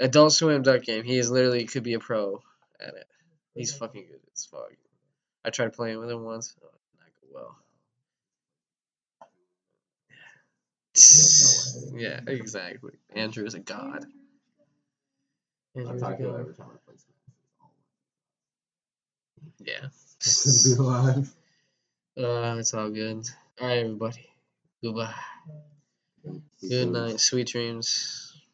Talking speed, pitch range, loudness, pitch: 105 wpm, 115-145 Hz, -21 LUFS, 125 Hz